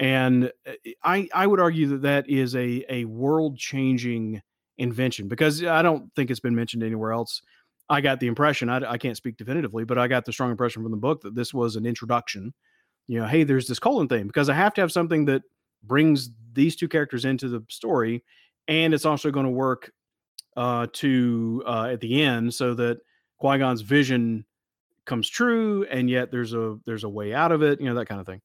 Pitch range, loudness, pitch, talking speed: 120-145 Hz, -24 LUFS, 125 Hz, 215 wpm